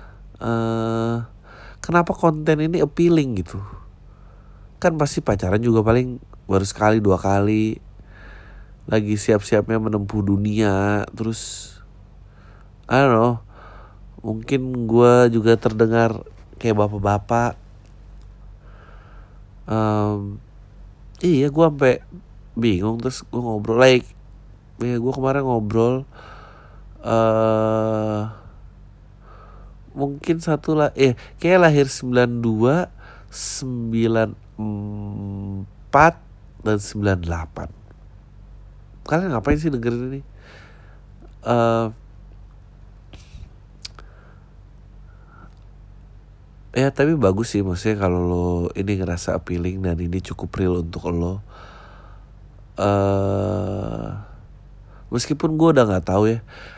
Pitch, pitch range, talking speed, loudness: 110 Hz, 100-120 Hz, 90 wpm, -20 LUFS